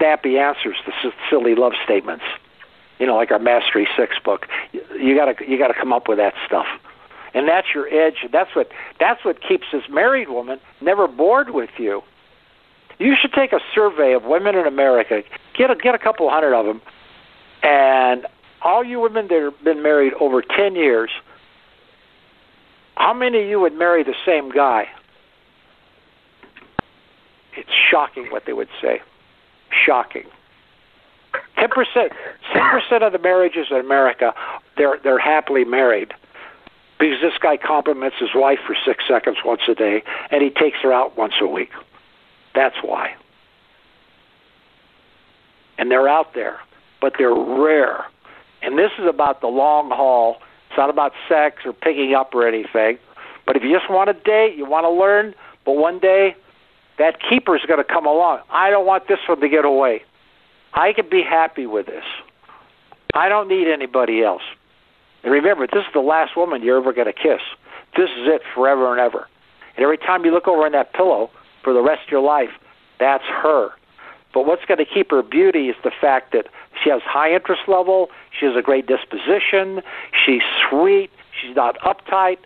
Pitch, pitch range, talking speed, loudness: 165 Hz, 135-215 Hz, 175 wpm, -17 LUFS